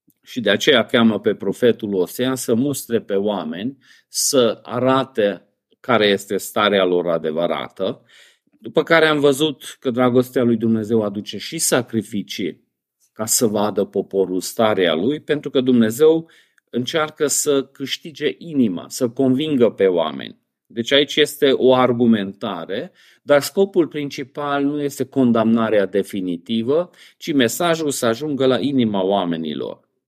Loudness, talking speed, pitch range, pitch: -19 LUFS, 130 wpm, 105-145 Hz, 125 Hz